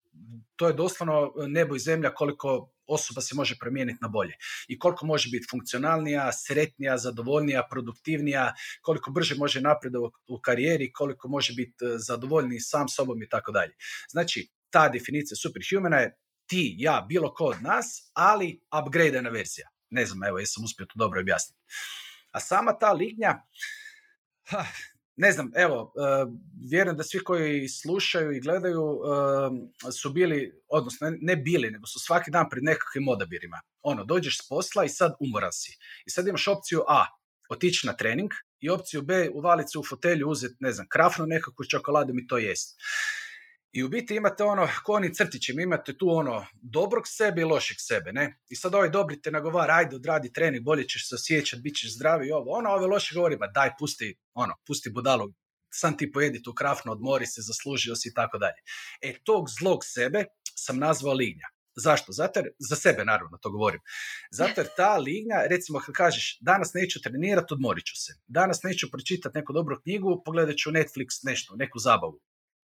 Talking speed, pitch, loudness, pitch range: 175 wpm, 150 Hz, -27 LUFS, 130-175 Hz